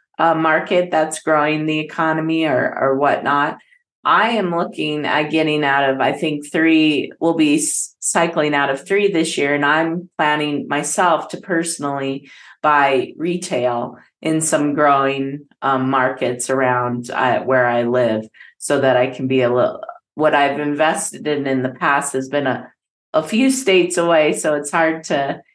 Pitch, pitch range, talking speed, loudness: 150 Hz, 135-165 Hz, 165 wpm, -17 LUFS